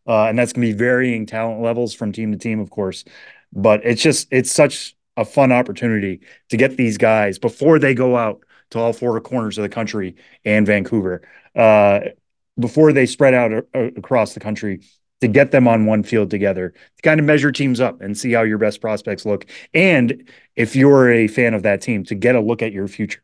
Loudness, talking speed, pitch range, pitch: -17 LUFS, 220 wpm, 105-125 Hz, 115 Hz